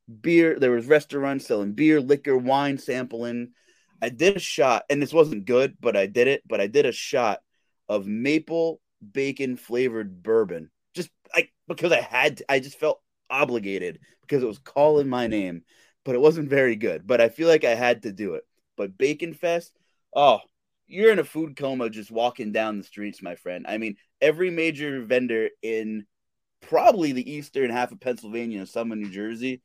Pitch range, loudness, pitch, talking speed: 115-160 Hz, -24 LUFS, 135 Hz, 190 wpm